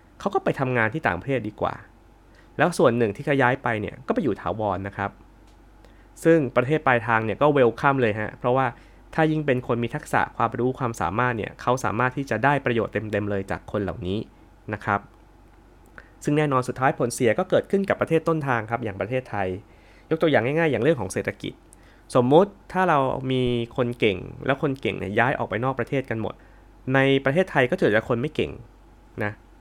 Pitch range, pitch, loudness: 105-135 Hz, 115 Hz, -24 LUFS